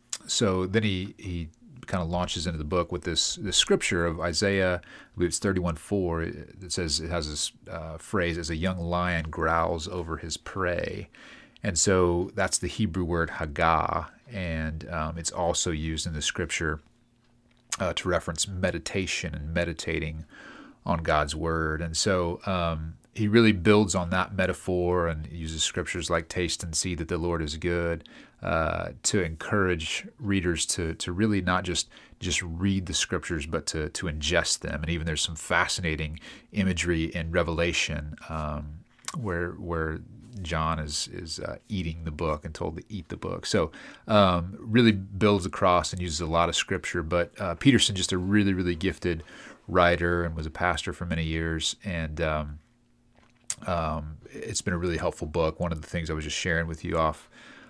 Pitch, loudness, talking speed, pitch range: 85 Hz, -27 LUFS, 175 wpm, 80-95 Hz